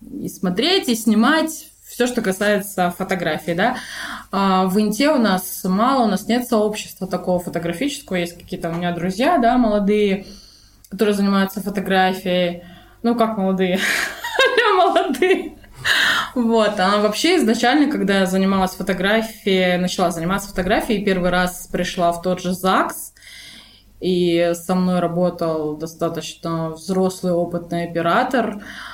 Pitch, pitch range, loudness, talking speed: 195 Hz, 180-230 Hz, -19 LUFS, 125 wpm